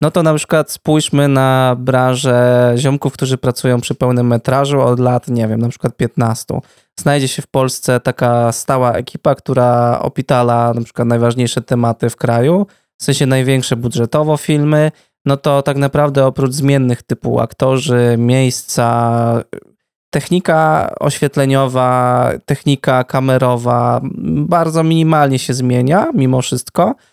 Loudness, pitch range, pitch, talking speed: -14 LUFS, 125-145 Hz, 130 Hz, 130 wpm